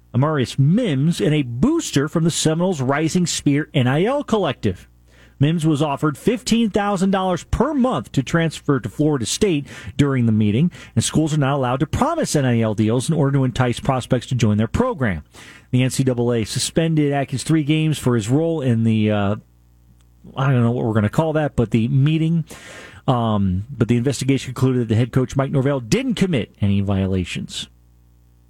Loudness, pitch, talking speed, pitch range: -19 LUFS, 135 Hz, 175 wpm, 115-155 Hz